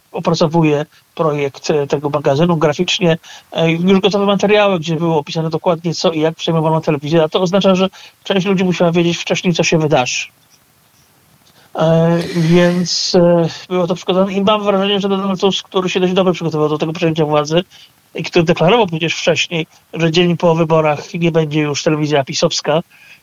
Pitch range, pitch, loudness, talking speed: 160-185 Hz, 170 Hz, -15 LUFS, 160 wpm